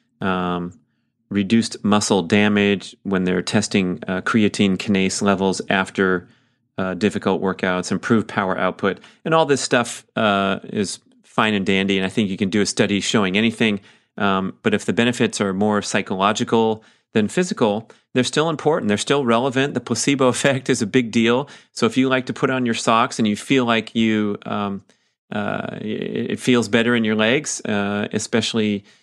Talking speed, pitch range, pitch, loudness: 175 wpm, 100-125 Hz, 110 Hz, -20 LUFS